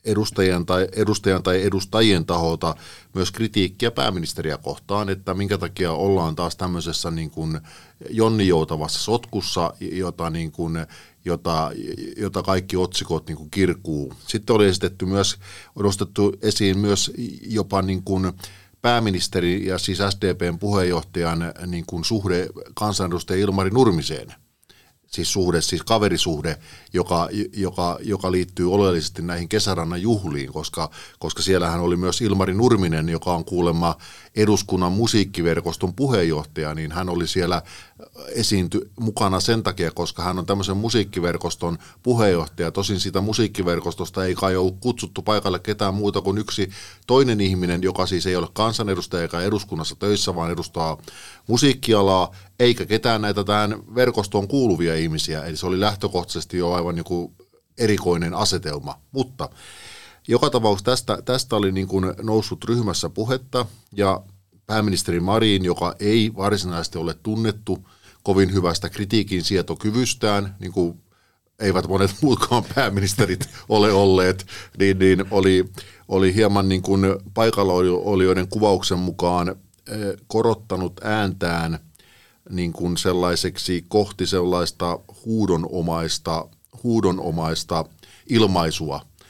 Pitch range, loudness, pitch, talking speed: 85-105 Hz, -22 LUFS, 95 Hz, 125 wpm